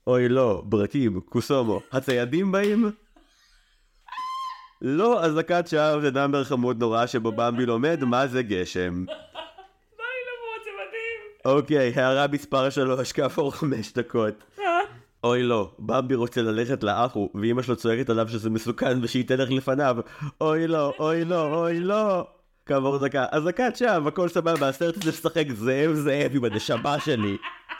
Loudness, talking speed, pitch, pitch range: -25 LUFS, 140 wpm, 140 Hz, 120-175 Hz